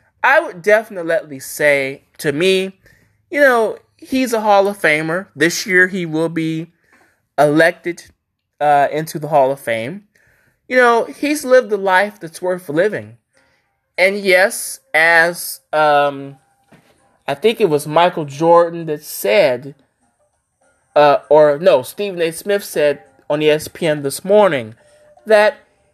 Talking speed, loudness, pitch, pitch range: 135 wpm, -15 LUFS, 165 Hz, 150-200 Hz